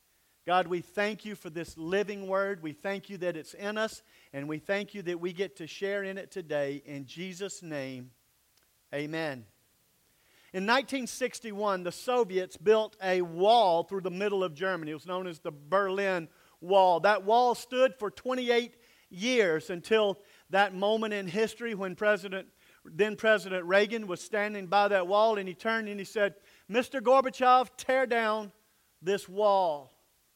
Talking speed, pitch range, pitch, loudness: 165 wpm, 175-215 Hz, 195 Hz, -29 LUFS